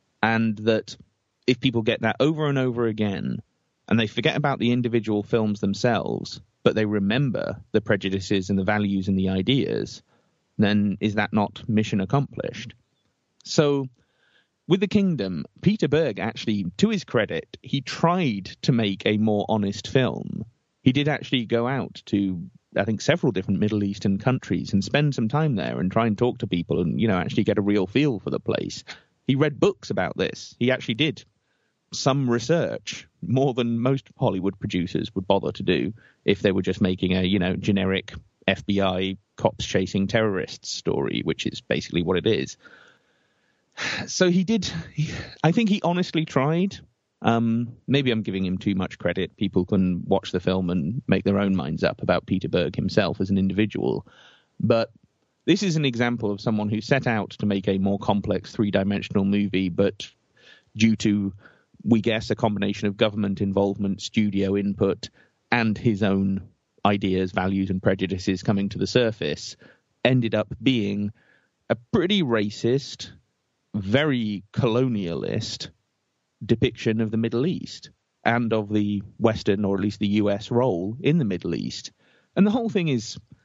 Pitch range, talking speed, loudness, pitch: 100-130 Hz, 170 wpm, -24 LUFS, 110 Hz